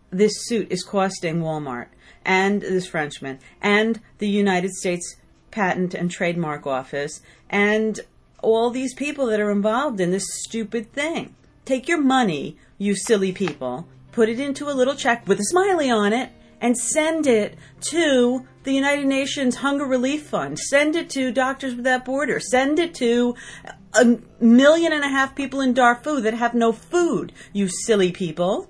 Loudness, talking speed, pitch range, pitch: -21 LUFS, 165 wpm, 190-270 Hz, 230 Hz